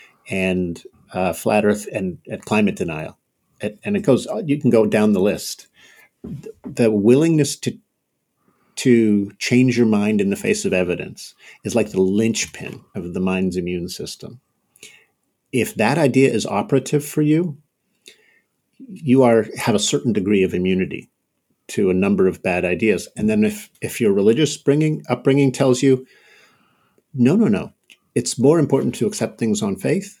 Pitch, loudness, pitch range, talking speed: 125 Hz, -19 LUFS, 100-150 Hz, 155 wpm